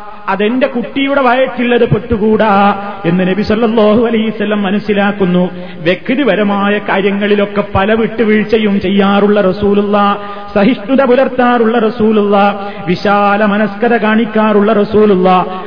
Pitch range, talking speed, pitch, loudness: 200-225 Hz, 85 wpm, 205 Hz, -11 LUFS